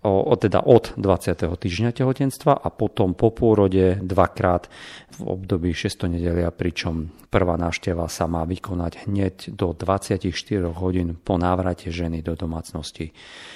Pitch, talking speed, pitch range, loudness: 90 Hz, 130 wpm, 85-100 Hz, -22 LUFS